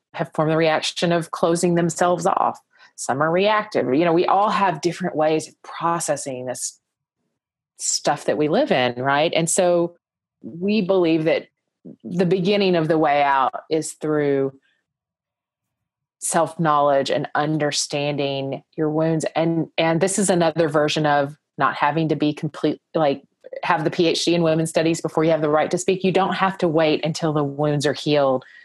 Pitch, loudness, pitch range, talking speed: 160 Hz, -20 LUFS, 150-175 Hz, 170 wpm